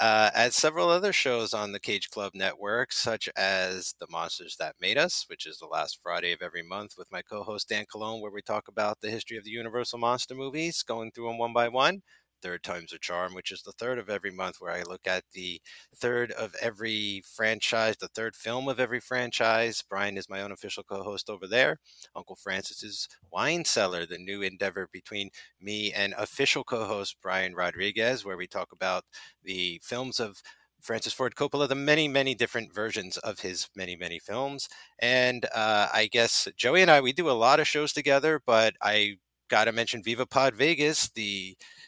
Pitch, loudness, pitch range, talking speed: 110 Hz, -28 LUFS, 100-125 Hz, 200 wpm